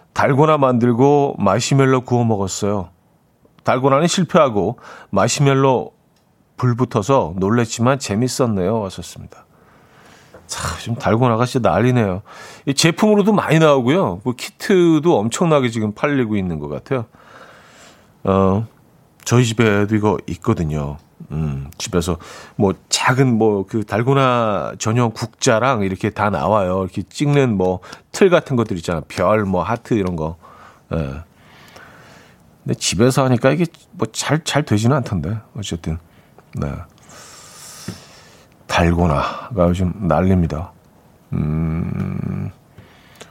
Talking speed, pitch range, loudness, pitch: 250 characters per minute, 90-135 Hz, -18 LUFS, 115 Hz